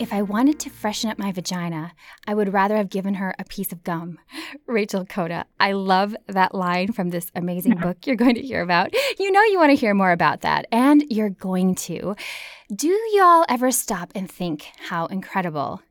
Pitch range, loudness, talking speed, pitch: 180-240 Hz, -21 LUFS, 205 wpm, 200 Hz